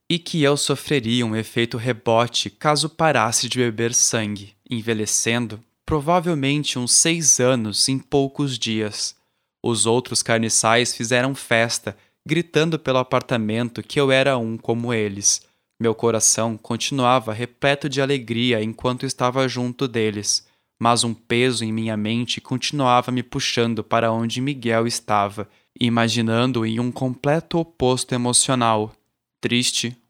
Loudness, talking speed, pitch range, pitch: -20 LUFS, 130 wpm, 115-130 Hz, 120 Hz